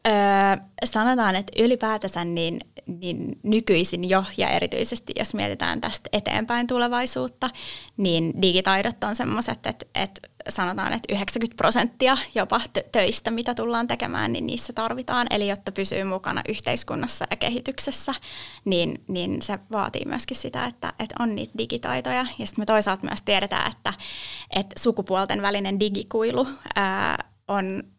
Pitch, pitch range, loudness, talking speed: 215 Hz, 195-240 Hz, -24 LUFS, 135 wpm